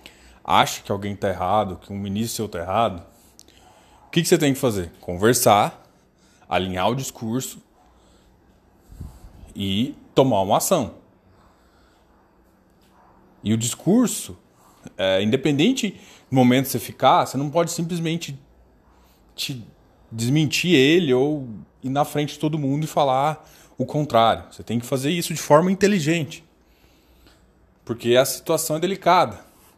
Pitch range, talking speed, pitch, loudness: 95-150 Hz, 135 wpm, 120 Hz, -21 LUFS